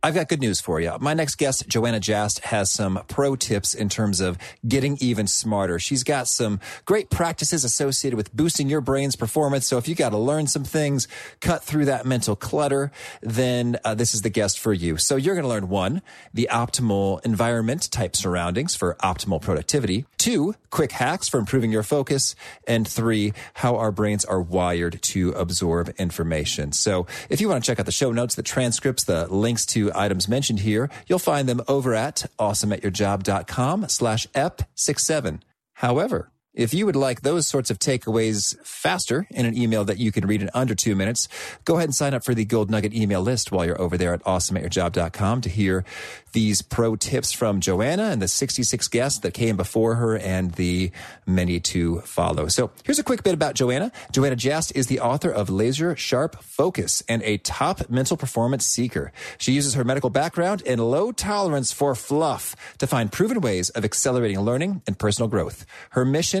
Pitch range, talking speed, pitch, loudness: 100-135 Hz, 190 wpm, 115 Hz, -23 LUFS